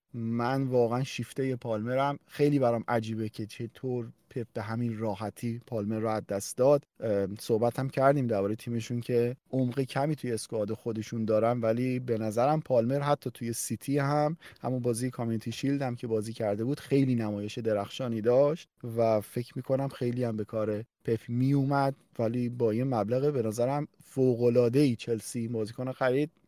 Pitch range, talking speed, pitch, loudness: 115-135 Hz, 160 wpm, 120 Hz, -30 LUFS